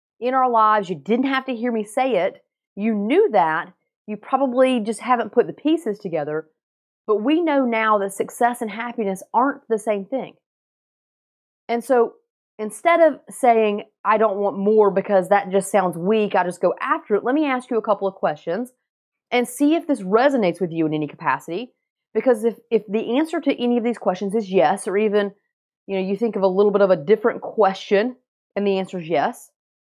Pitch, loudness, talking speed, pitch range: 220 Hz, -20 LUFS, 205 wpm, 195-250 Hz